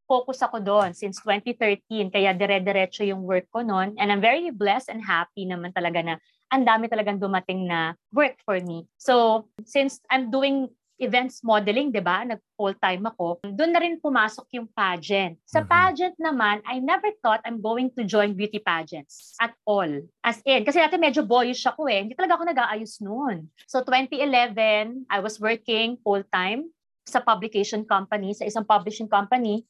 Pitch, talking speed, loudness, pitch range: 220 Hz, 170 wpm, -24 LUFS, 200-255 Hz